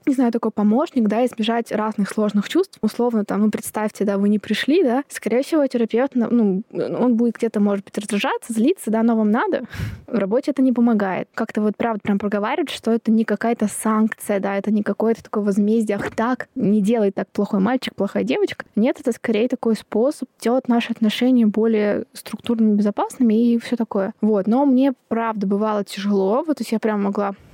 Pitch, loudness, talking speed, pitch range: 225 Hz, -20 LUFS, 195 wpm, 210-240 Hz